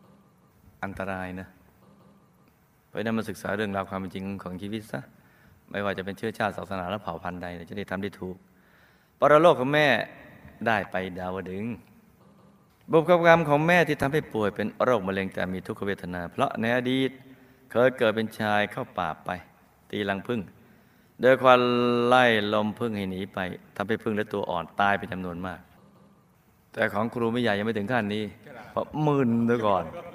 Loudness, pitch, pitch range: -26 LUFS, 105 Hz, 95-120 Hz